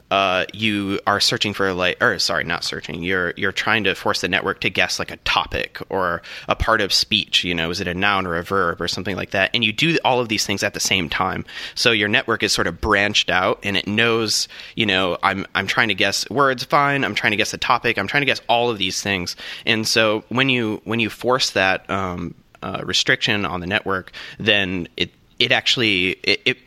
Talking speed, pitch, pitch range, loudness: 235 wpm, 100 Hz, 95-115 Hz, -19 LUFS